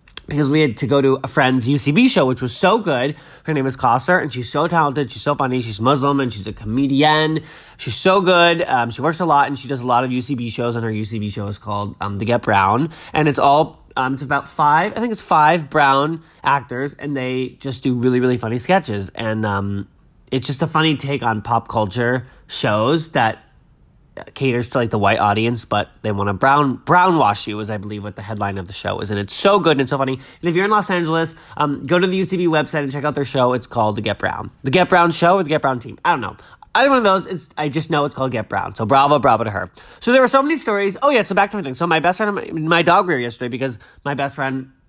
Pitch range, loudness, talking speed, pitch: 115-160 Hz, -18 LUFS, 265 wpm, 135 Hz